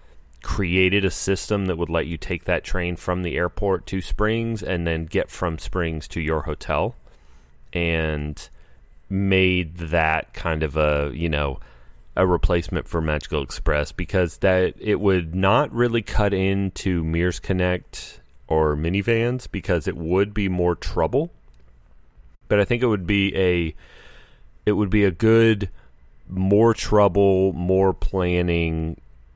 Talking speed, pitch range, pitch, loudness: 145 wpm, 75-95 Hz, 90 Hz, -22 LUFS